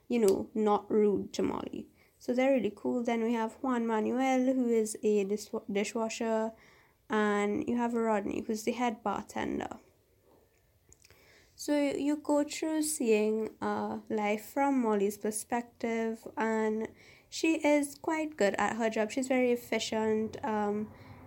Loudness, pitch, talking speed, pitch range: -31 LUFS, 225 Hz, 140 wpm, 215-255 Hz